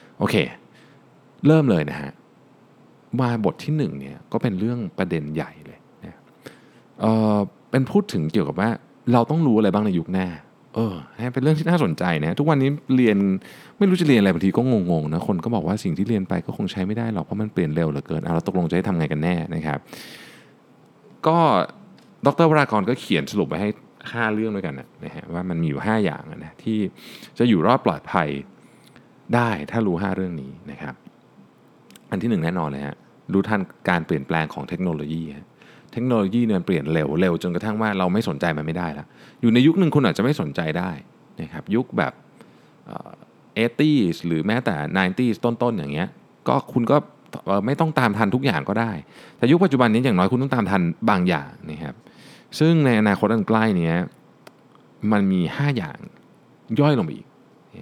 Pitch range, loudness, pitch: 85-120 Hz, -22 LUFS, 105 Hz